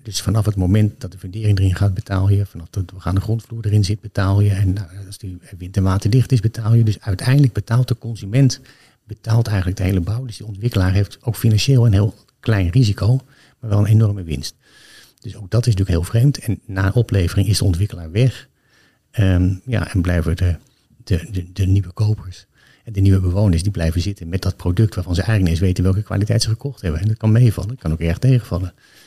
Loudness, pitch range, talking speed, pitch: -18 LUFS, 95-115 Hz, 225 wpm, 100 Hz